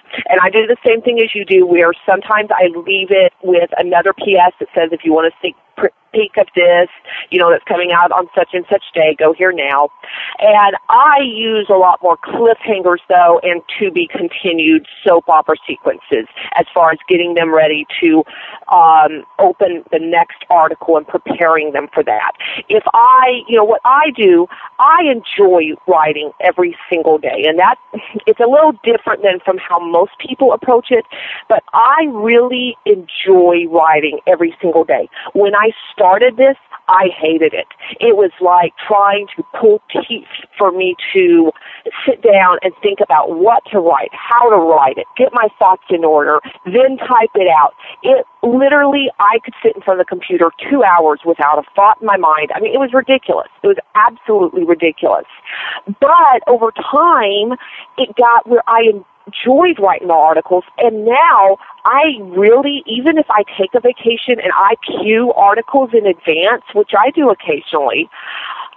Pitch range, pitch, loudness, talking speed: 175-265 Hz, 205 Hz, -12 LUFS, 175 wpm